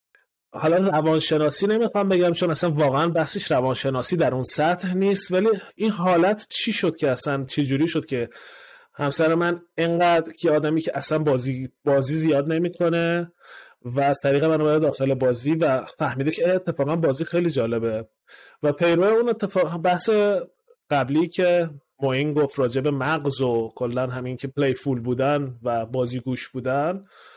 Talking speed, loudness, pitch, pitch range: 155 wpm, -22 LUFS, 155 Hz, 135-175 Hz